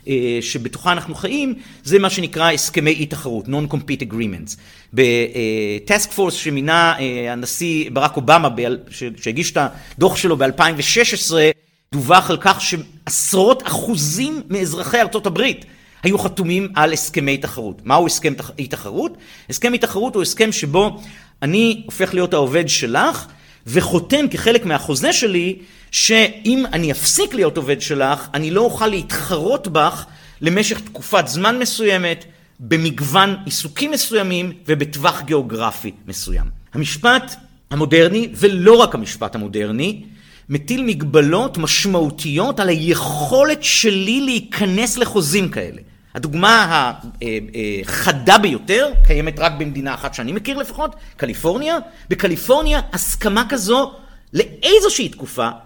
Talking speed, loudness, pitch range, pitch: 110 wpm, -17 LUFS, 140-210 Hz, 170 Hz